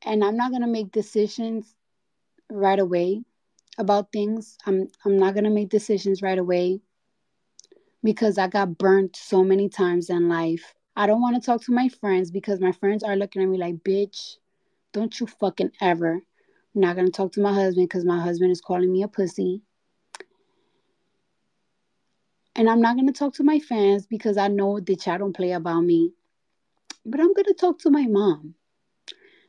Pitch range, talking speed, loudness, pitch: 185-225 Hz, 185 wpm, -23 LUFS, 200 Hz